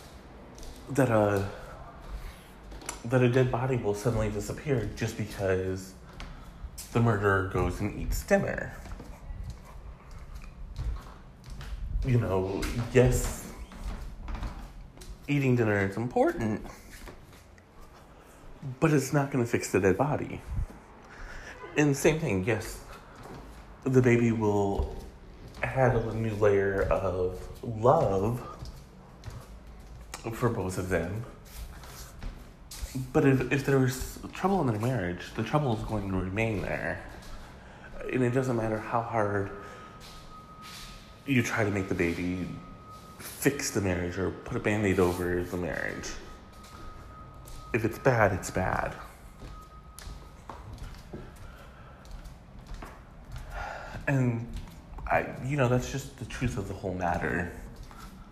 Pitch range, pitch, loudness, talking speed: 85-125 Hz, 100 Hz, -29 LUFS, 110 wpm